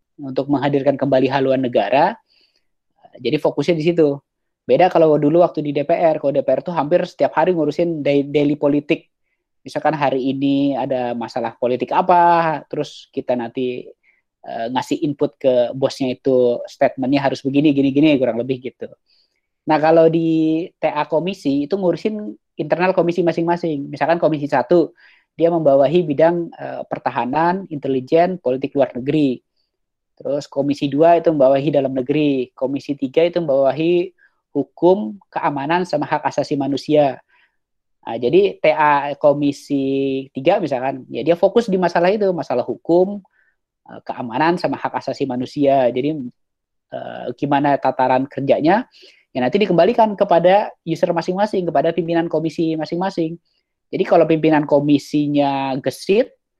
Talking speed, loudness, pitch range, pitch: 135 wpm, -18 LUFS, 135-170 Hz, 150 Hz